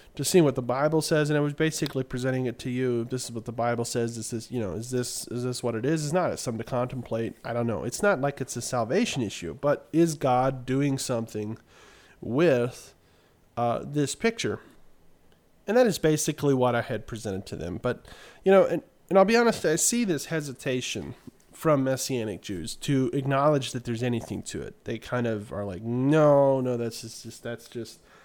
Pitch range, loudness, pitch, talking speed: 115-145 Hz, -26 LUFS, 125 Hz, 210 wpm